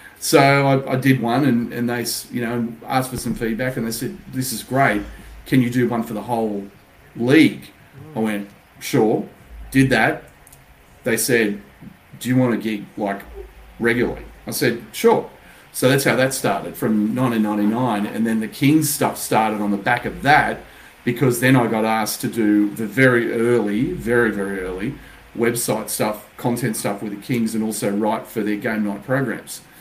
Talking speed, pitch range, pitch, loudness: 185 wpm, 105-125 Hz, 115 Hz, -20 LUFS